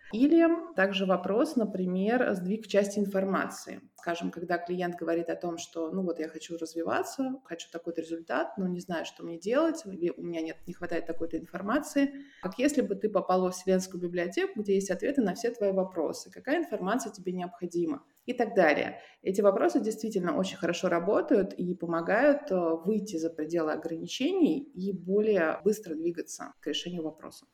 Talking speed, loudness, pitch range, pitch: 165 wpm, -30 LUFS, 170-235 Hz, 190 Hz